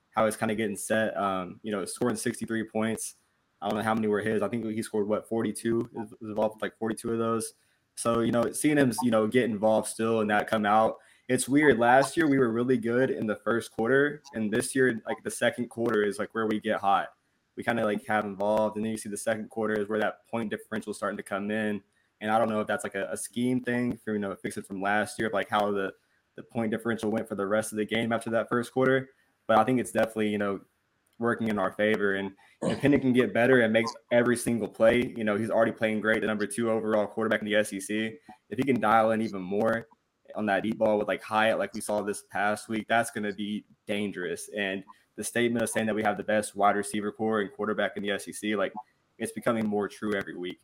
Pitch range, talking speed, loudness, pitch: 105-115 Hz, 255 wpm, -28 LUFS, 110 Hz